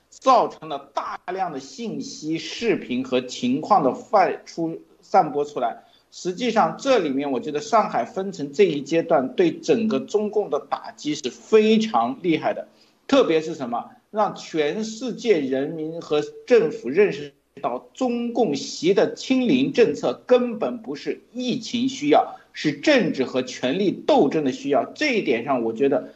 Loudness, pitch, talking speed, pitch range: -22 LUFS, 215 Hz, 235 characters per minute, 160-255 Hz